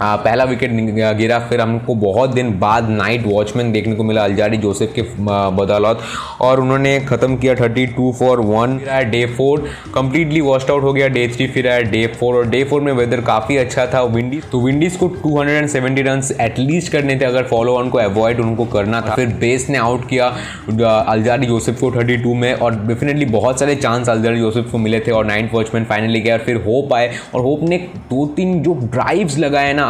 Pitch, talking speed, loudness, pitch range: 120 Hz, 205 wpm, -15 LUFS, 115-130 Hz